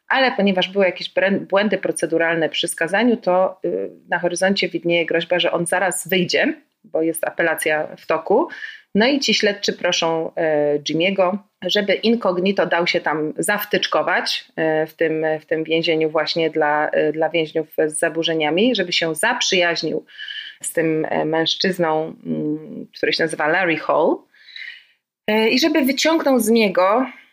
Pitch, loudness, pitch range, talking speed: 175 Hz, -19 LUFS, 160-205 Hz, 135 wpm